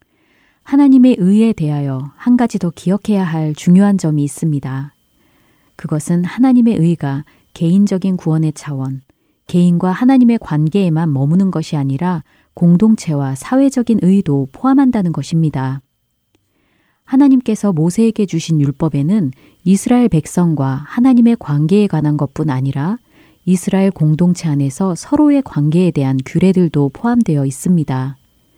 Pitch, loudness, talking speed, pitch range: 170 Hz, -14 LUFS, 315 characters per minute, 145-205 Hz